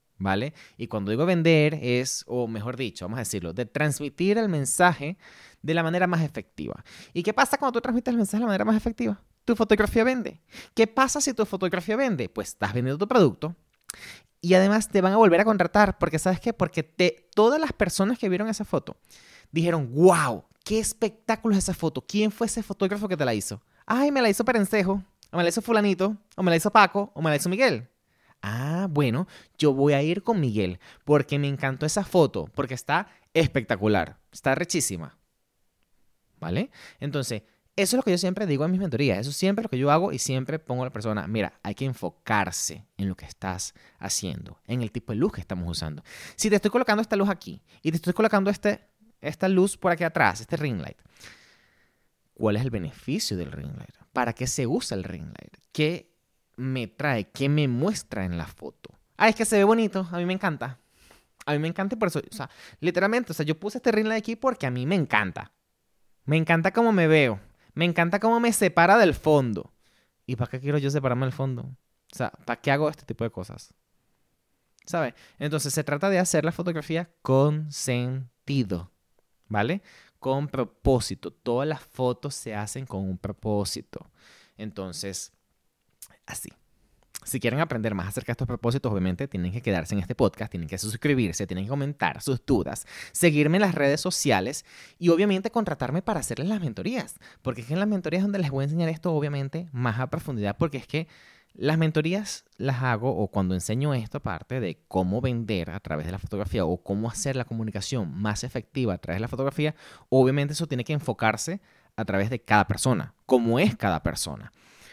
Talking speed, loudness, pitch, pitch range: 205 wpm, -25 LUFS, 145 Hz, 115-185 Hz